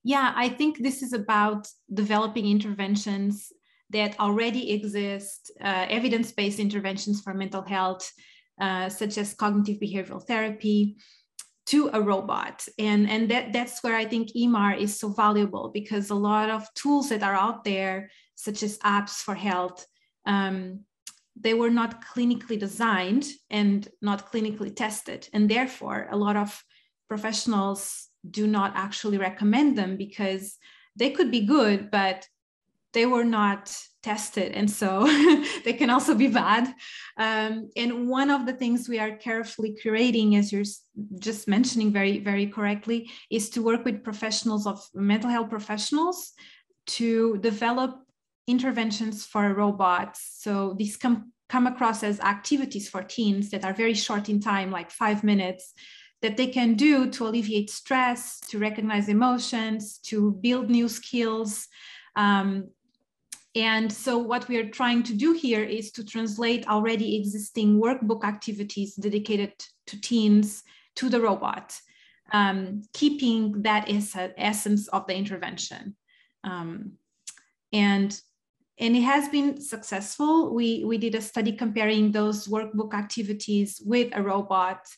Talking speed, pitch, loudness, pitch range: 140 wpm, 215 Hz, -26 LUFS, 205-235 Hz